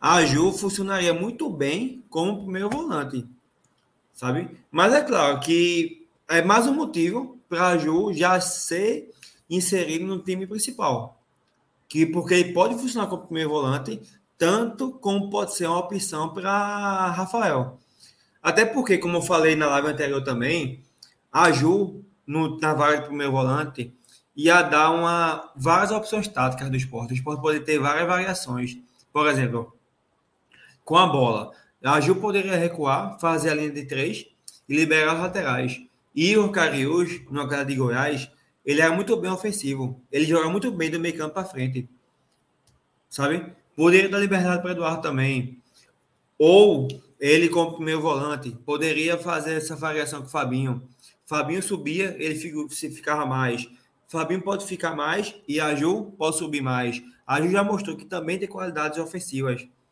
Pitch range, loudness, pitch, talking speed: 140-185 Hz, -23 LUFS, 160 Hz, 155 wpm